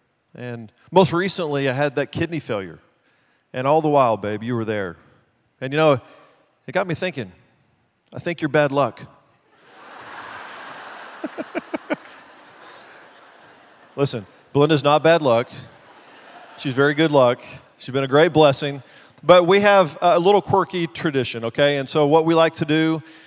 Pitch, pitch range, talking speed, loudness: 145 Hz, 130-160 Hz, 145 wpm, -19 LUFS